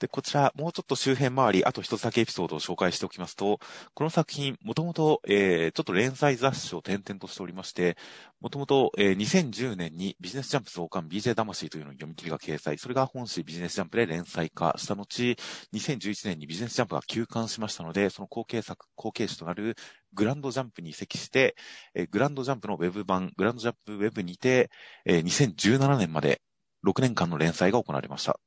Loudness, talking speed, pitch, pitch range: -28 LUFS, 430 characters per minute, 110 Hz, 90-130 Hz